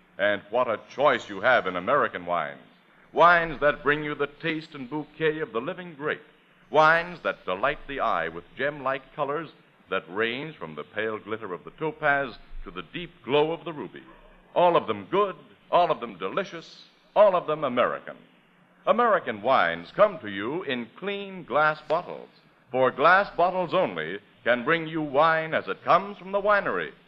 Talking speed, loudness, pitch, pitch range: 180 wpm, -25 LUFS, 155 Hz, 140-170 Hz